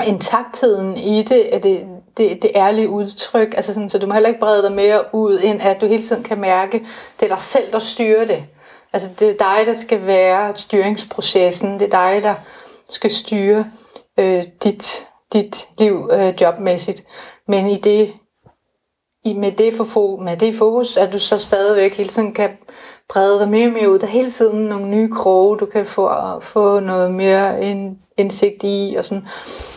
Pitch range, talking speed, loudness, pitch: 195-220 Hz, 190 wpm, -16 LUFS, 205 Hz